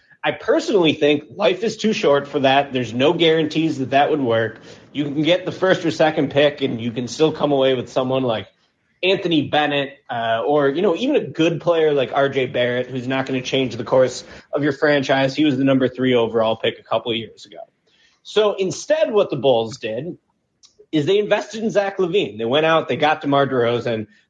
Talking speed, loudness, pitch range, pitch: 215 wpm, -19 LUFS, 130-160 Hz, 140 Hz